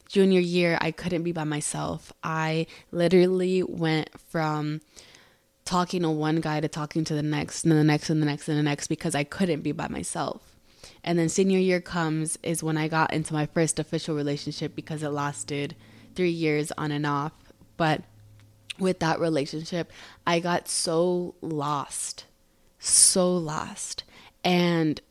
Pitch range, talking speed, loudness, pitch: 150-170 Hz, 165 wpm, -26 LUFS, 160 Hz